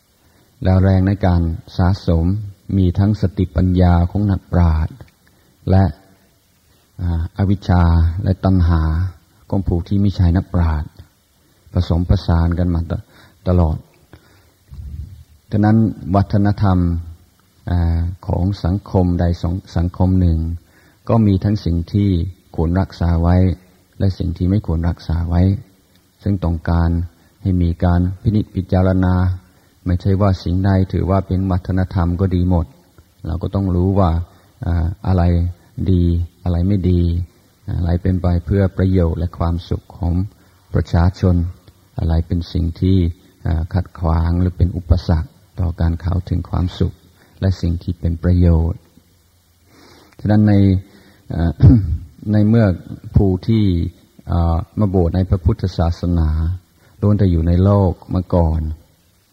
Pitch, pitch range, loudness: 90 Hz, 85-95 Hz, -18 LUFS